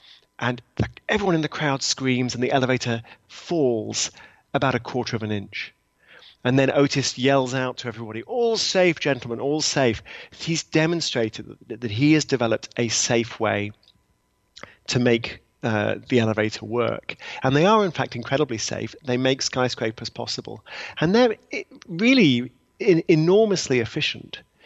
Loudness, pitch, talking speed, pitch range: -22 LUFS, 130 Hz, 145 wpm, 115-150 Hz